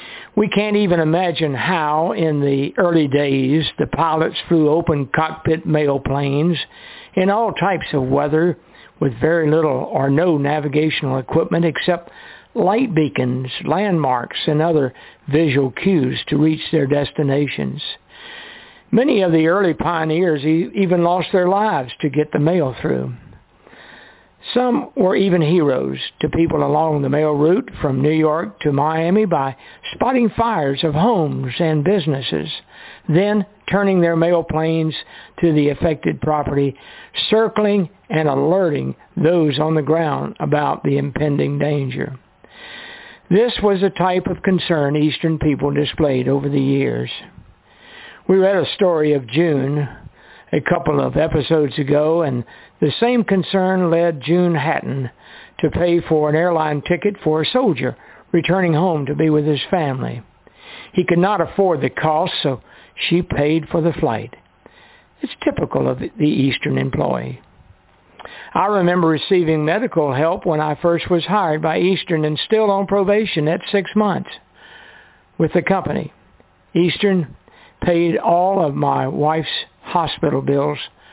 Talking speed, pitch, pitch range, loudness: 140 wpm, 160 Hz, 145-180 Hz, -18 LUFS